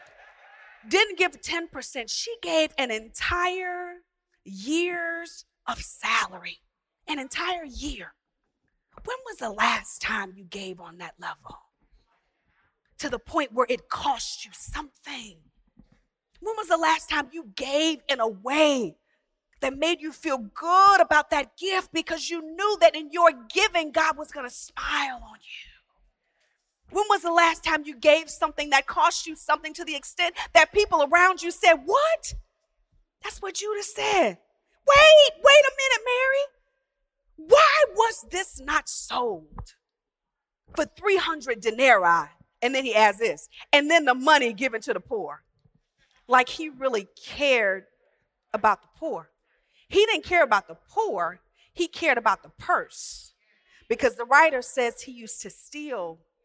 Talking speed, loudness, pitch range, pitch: 150 wpm, -23 LUFS, 265-350 Hz, 310 Hz